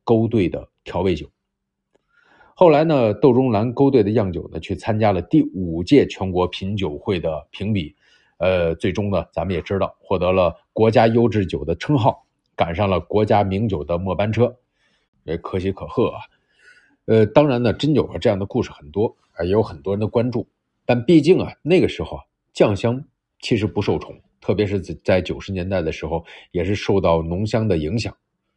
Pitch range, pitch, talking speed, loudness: 90-115 Hz, 100 Hz, 270 characters per minute, -20 LUFS